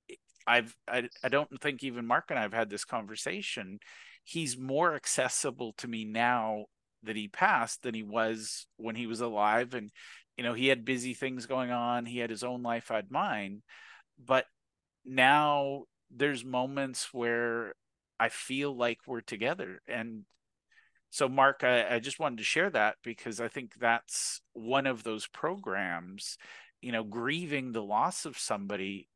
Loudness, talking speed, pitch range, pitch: -32 LUFS, 165 wpm, 110-130 Hz, 120 Hz